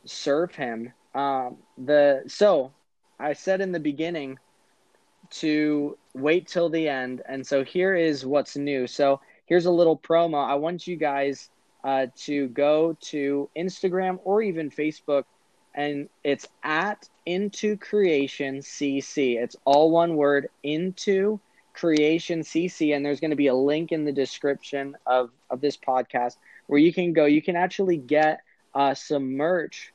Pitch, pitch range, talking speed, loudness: 150 Hz, 140-170 Hz, 150 wpm, -24 LUFS